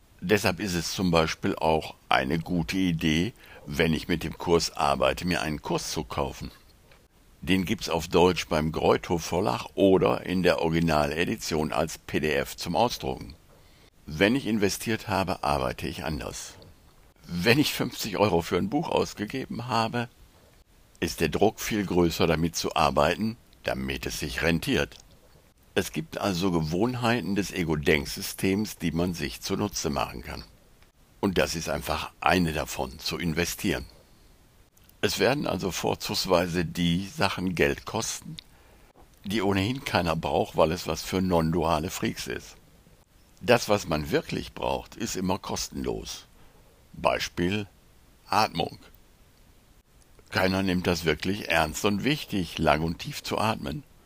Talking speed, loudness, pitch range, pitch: 140 wpm, -27 LUFS, 80-100 Hz, 90 Hz